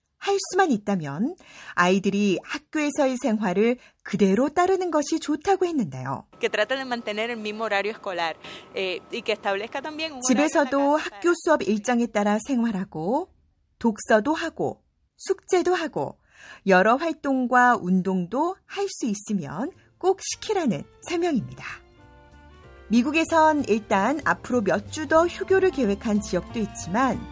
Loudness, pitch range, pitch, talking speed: -23 LUFS, 205-315 Hz, 250 Hz, 235 characters per minute